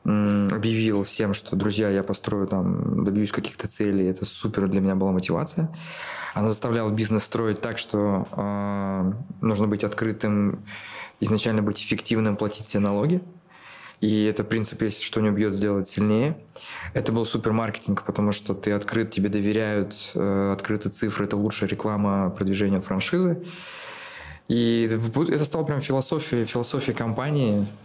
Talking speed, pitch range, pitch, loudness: 145 wpm, 100-115 Hz, 105 Hz, -24 LUFS